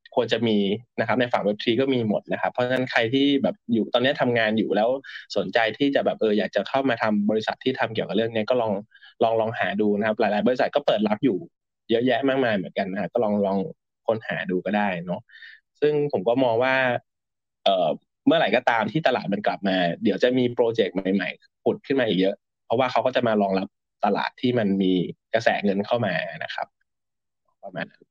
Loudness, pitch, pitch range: -23 LUFS, 110 Hz, 100-130 Hz